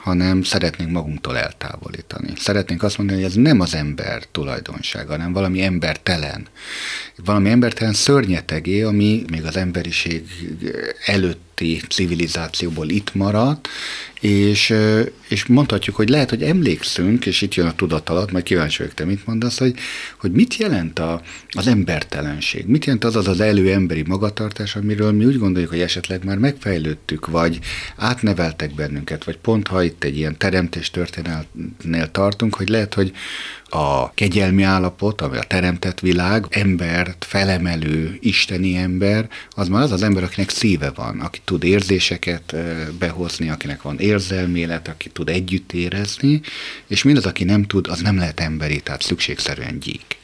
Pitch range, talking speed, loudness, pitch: 85-105 Hz, 150 wpm, -19 LUFS, 95 Hz